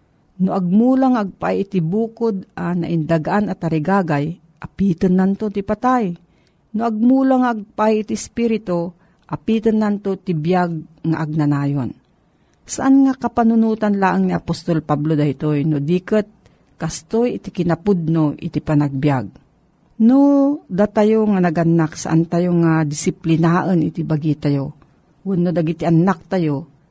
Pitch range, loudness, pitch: 160-215 Hz, -18 LUFS, 180 Hz